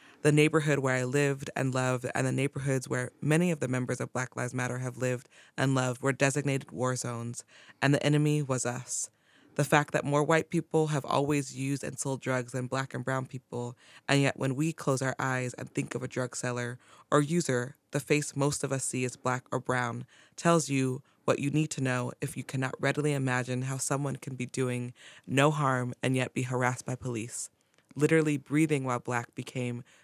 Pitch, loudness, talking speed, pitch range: 130 Hz, -30 LUFS, 210 wpm, 125-145 Hz